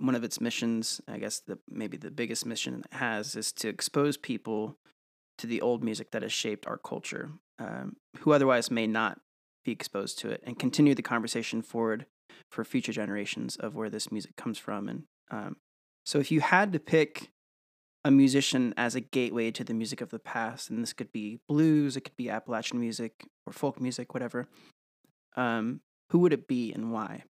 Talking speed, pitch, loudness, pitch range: 195 wpm, 120 Hz, -30 LUFS, 115-140 Hz